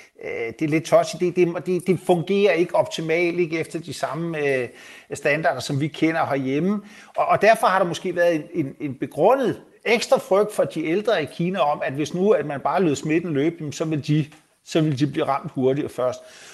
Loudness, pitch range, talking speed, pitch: -22 LUFS, 150-180 Hz, 215 wpm, 165 Hz